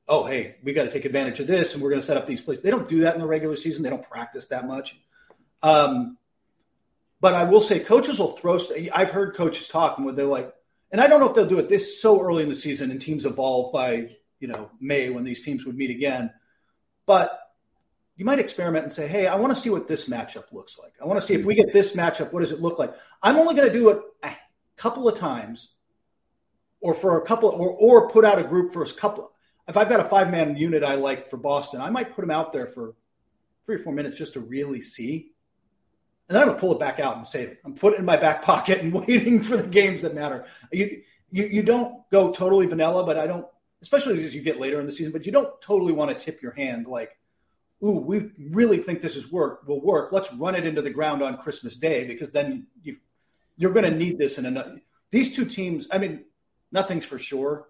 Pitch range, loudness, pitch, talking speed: 150-215 Hz, -22 LUFS, 175 Hz, 250 wpm